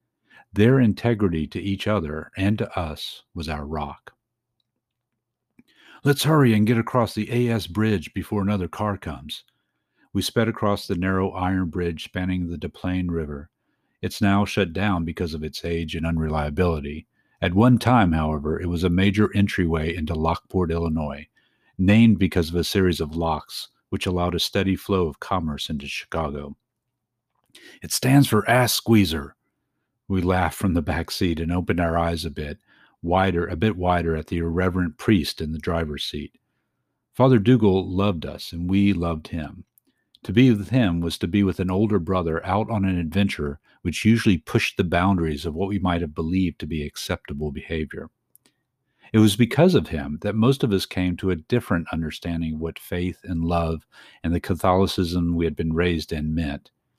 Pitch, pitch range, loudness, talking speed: 90 Hz, 80-105 Hz, -23 LUFS, 175 wpm